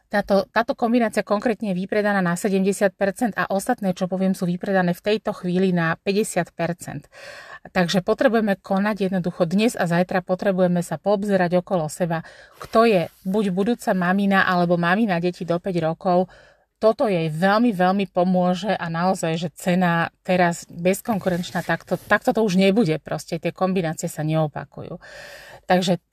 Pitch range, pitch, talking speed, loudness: 175-205 Hz, 185 Hz, 145 wpm, -21 LUFS